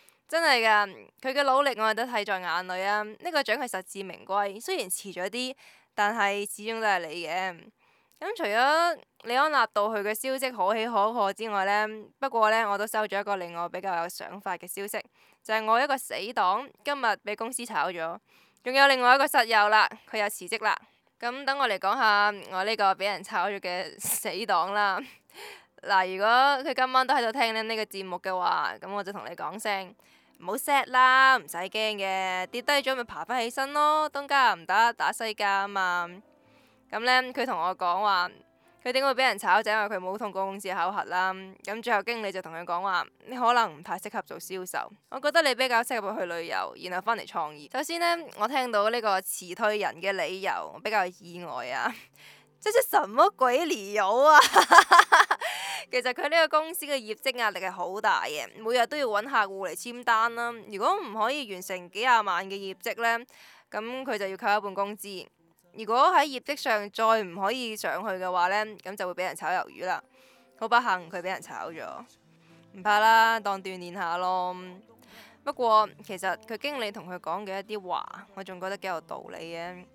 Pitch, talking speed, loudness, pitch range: 210 Hz, 280 characters per minute, -26 LUFS, 190-245 Hz